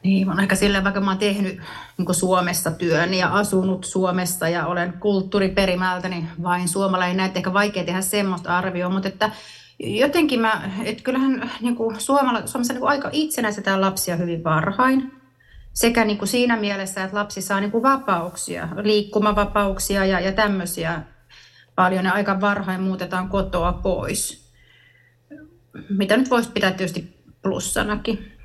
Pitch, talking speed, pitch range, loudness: 195 Hz, 135 wpm, 180-210 Hz, -21 LUFS